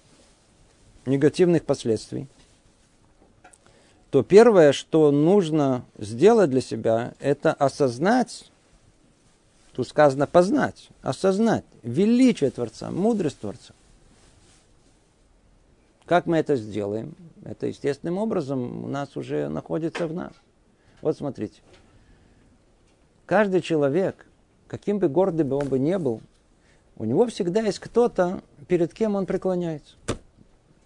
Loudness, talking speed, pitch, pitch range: -23 LUFS, 105 wpm, 150 Hz, 125-185 Hz